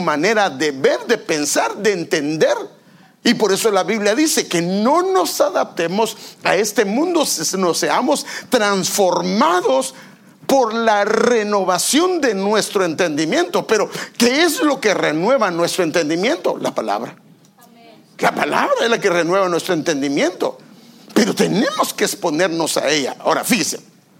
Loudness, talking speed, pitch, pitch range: -17 LUFS, 140 wpm, 215 Hz, 185-260 Hz